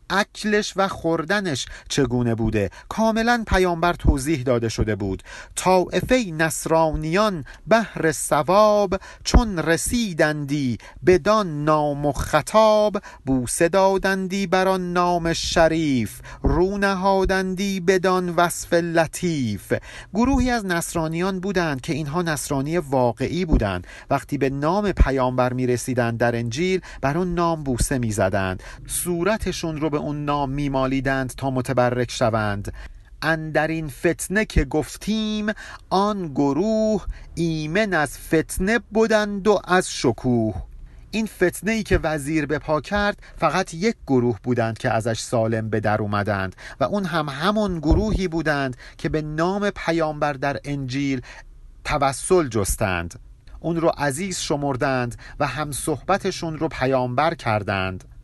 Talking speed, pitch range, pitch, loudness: 120 wpm, 130-185 Hz, 155 Hz, -22 LUFS